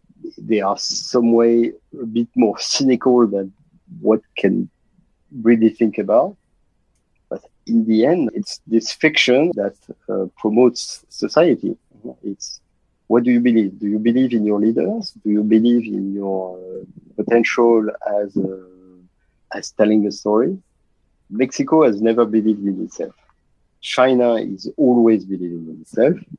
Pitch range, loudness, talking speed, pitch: 95-120 Hz, -17 LUFS, 140 wpm, 110 Hz